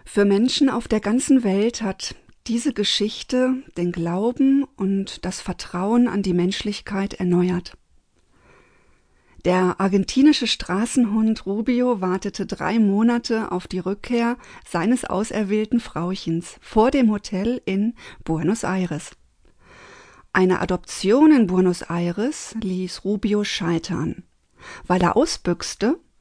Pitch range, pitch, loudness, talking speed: 185-235 Hz, 205 Hz, -21 LUFS, 110 wpm